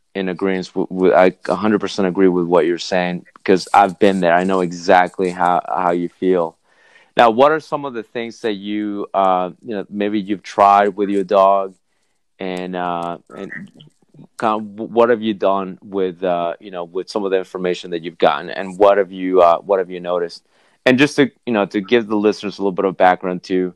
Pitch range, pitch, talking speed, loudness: 90-105 Hz, 95 Hz, 215 wpm, -17 LUFS